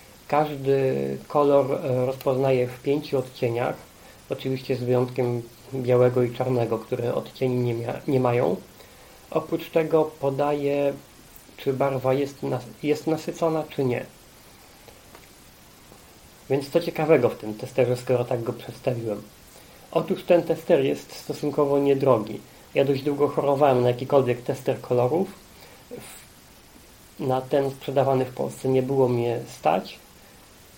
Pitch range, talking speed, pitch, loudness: 125-140 Hz, 120 wpm, 130 Hz, -24 LUFS